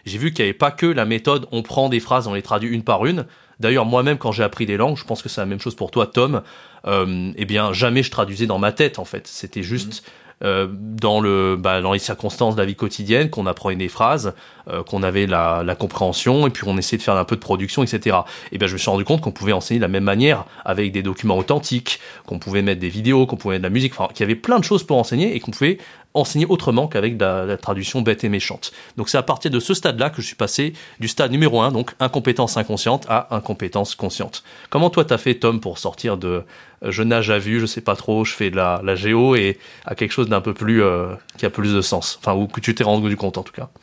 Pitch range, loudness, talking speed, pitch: 100-125 Hz, -19 LUFS, 270 wpm, 110 Hz